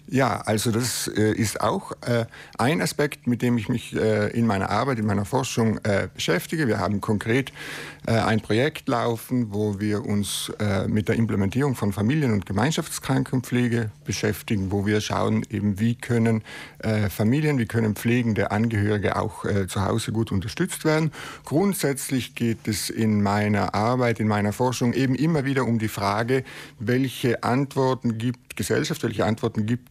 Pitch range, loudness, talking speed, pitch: 105-130 Hz, -24 LUFS, 150 wpm, 115 Hz